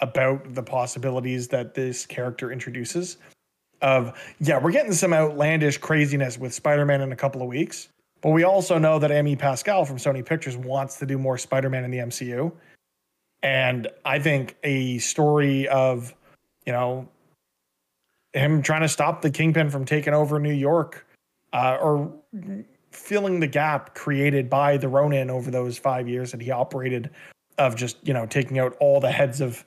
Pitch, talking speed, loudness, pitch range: 140 Hz, 170 wpm, -23 LUFS, 130-150 Hz